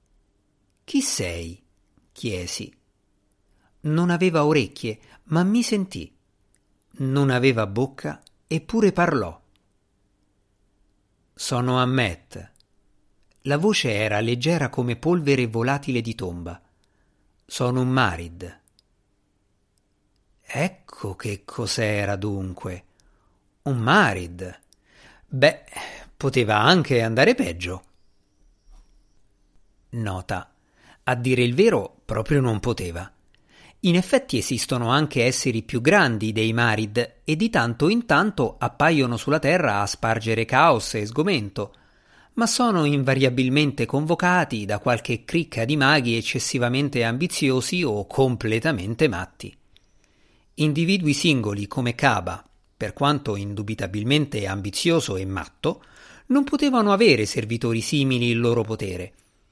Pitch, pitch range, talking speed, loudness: 115 Hz, 100-140 Hz, 100 wpm, -22 LUFS